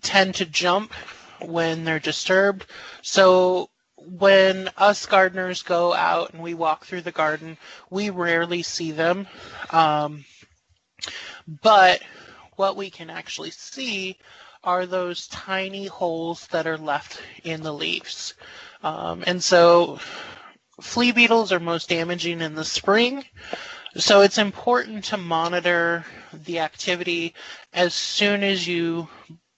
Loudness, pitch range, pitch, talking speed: -21 LUFS, 165-195 Hz, 175 Hz, 125 wpm